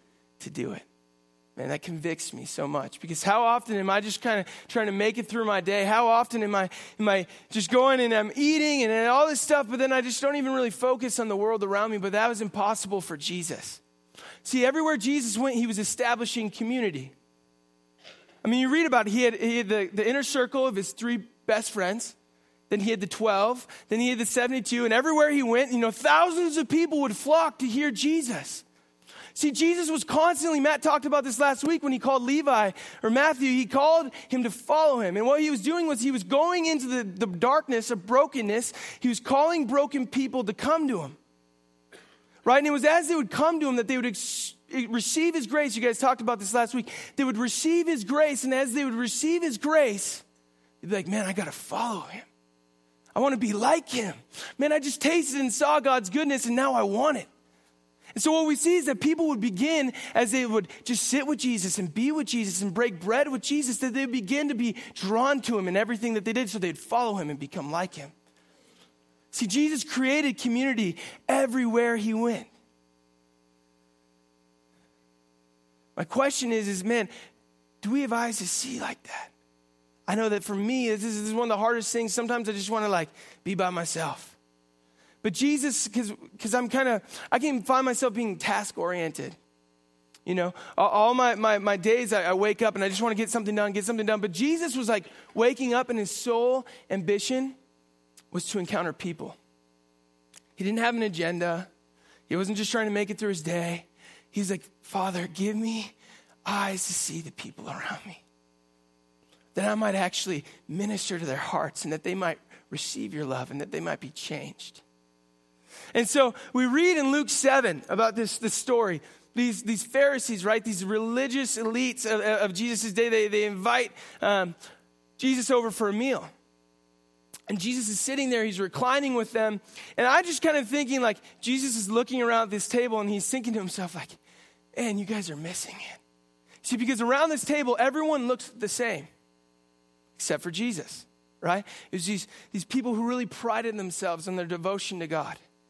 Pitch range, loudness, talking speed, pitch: 180-260 Hz, -26 LUFS, 205 wpm, 225 Hz